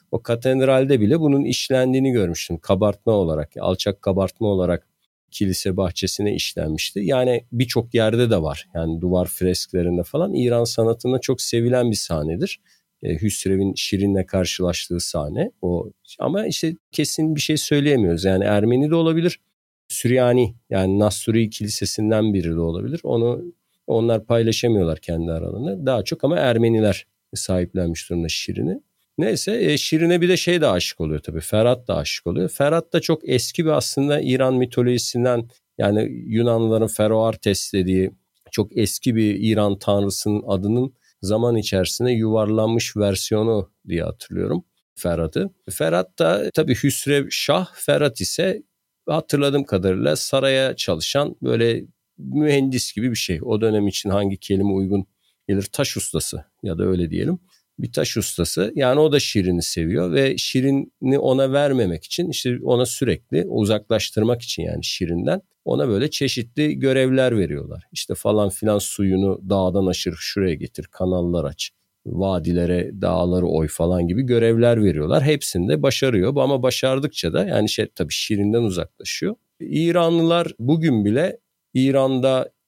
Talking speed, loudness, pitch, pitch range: 135 wpm, -20 LUFS, 110 Hz, 95-130 Hz